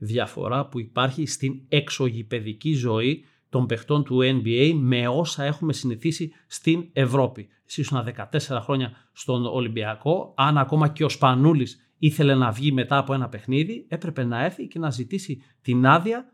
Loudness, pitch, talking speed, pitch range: -24 LUFS, 135 Hz, 150 wpm, 125-155 Hz